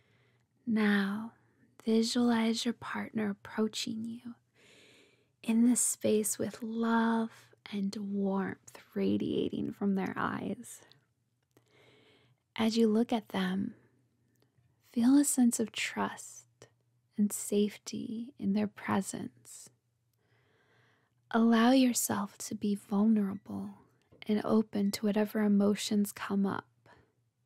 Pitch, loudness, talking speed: 205 Hz, -31 LUFS, 95 wpm